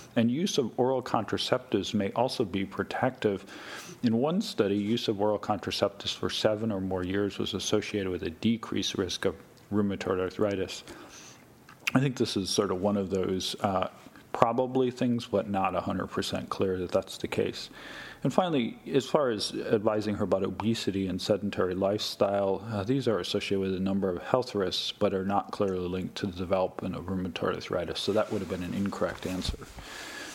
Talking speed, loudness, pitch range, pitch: 180 wpm, -30 LUFS, 95-110 Hz, 100 Hz